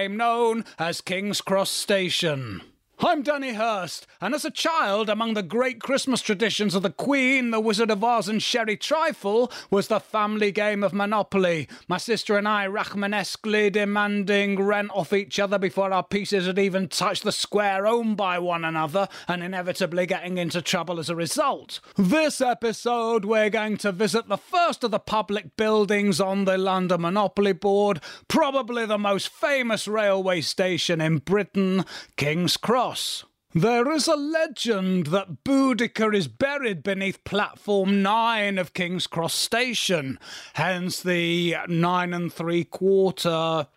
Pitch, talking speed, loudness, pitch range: 200 Hz, 150 wpm, -24 LUFS, 180-225 Hz